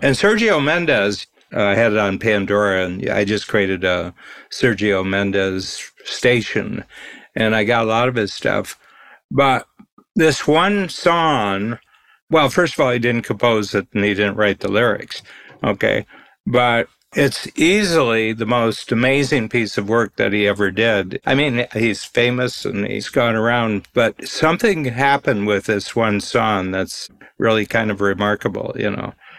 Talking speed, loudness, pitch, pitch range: 160 wpm, -18 LUFS, 115 Hz, 100-130 Hz